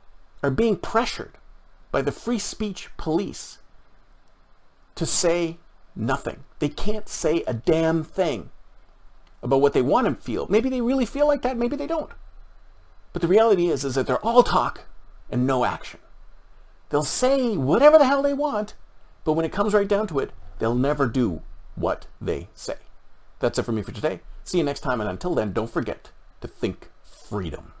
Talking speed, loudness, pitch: 180 wpm, -23 LUFS, 170 Hz